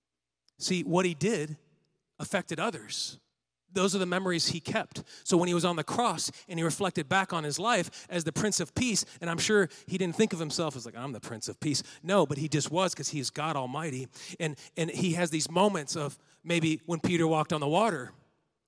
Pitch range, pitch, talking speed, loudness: 150-185 Hz, 165 Hz, 225 wpm, -30 LUFS